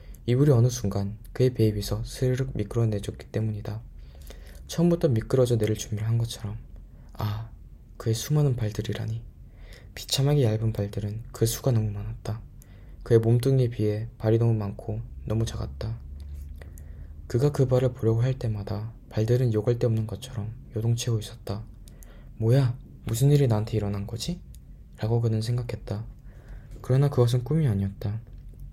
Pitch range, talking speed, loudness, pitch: 105-120 Hz, 320 characters per minute, -26 LUFS, 110 Hz